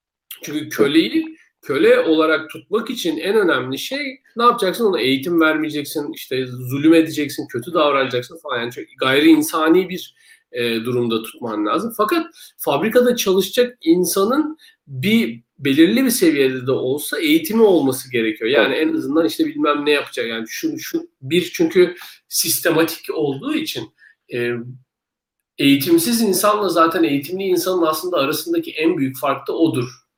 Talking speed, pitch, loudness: 135 wpm, 175 Hz, -18 LUFS